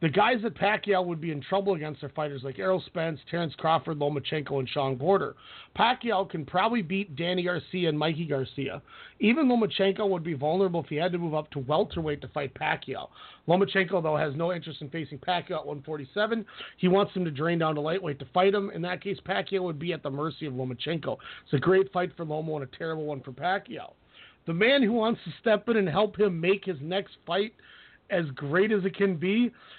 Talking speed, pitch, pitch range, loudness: 220 wpm, 170 Hz, 150-195 Hz, -28 LUFS